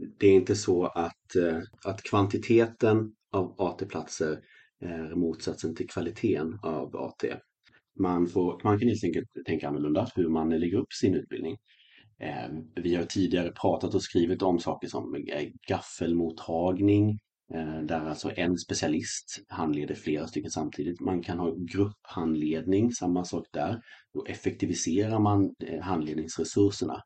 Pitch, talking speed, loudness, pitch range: 90 Hz, 130 wpm, -29 LUFS, 80-100 Hz